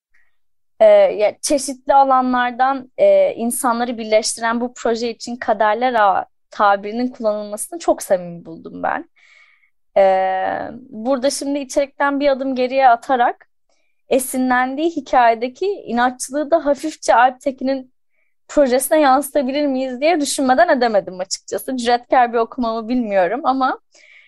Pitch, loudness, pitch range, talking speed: 255 Hz, -17 LUFS, 235-285 Hz, 105 wpm